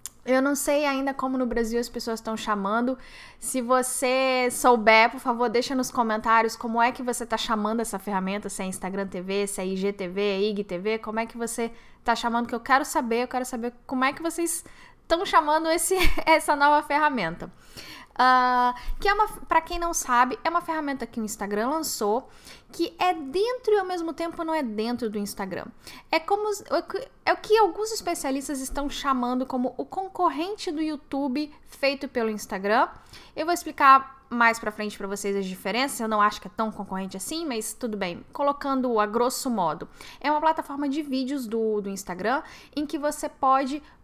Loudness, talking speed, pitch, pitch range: -25 LUFS, 190 wpm, 255 Hz, 225-310 Hz